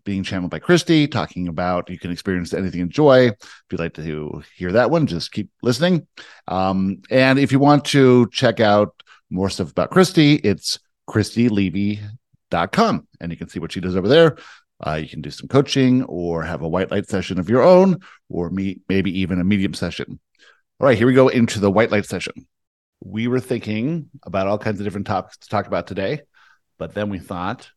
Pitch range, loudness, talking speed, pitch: 90-125 Hz, -19 LUFS, 205 wpm, 100 Hz